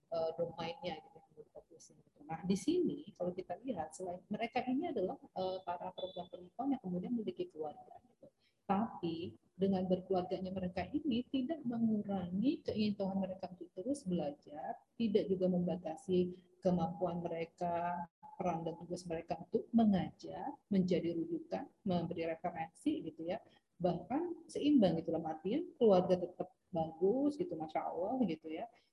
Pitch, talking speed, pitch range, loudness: 185 Hz, 130 wpm, 175-230 Hz, -38 LUFS